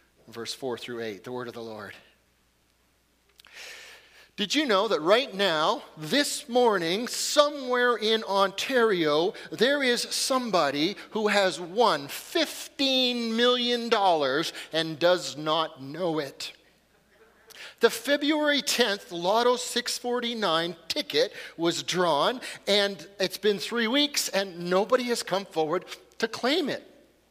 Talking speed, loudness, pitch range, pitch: 120 wpm, -26 LUFS, 160-250 Hz, 210 Hz